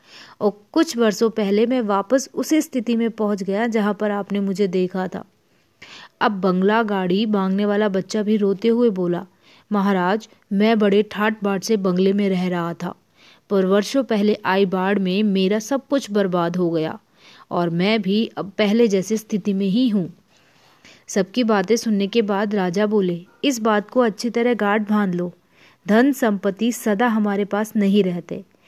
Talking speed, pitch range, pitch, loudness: 170 wpm, 195-225 Hz, 205 Hz, -20 LUFS